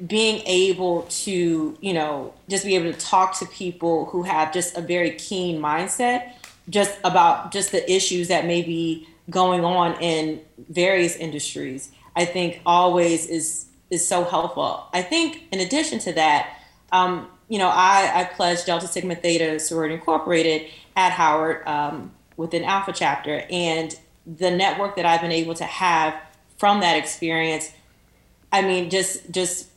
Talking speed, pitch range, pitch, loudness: 155 wpm, 160-185 Hz, 175 Hz, -22 LUFS